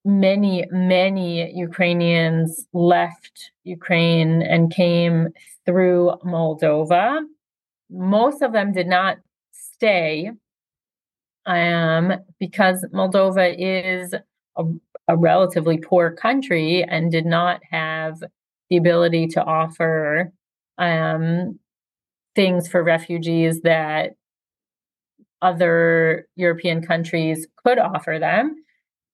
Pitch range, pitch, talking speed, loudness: 165-185 Hz, 175 Hz, 90 wpm, -19 LUFS